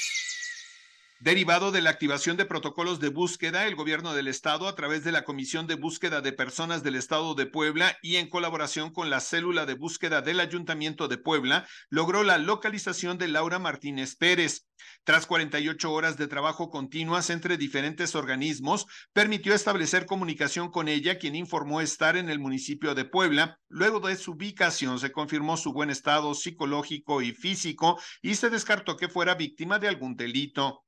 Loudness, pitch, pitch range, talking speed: -27 LUFS, 160 Hz, 150-180 Hz, 170 wpm